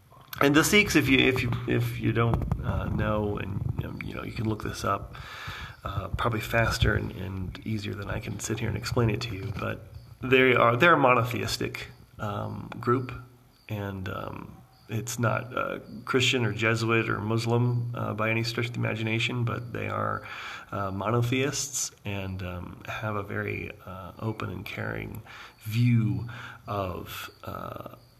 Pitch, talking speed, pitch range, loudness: 110 Hz, 165 wpm, 105-120 Hz, -27 LUFS